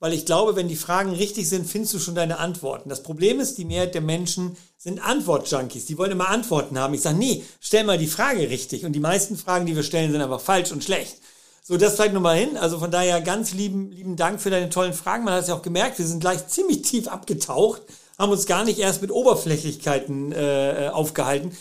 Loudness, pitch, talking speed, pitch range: -23 LUFS, 180 Hz, 235 wpm, 160-195 Hz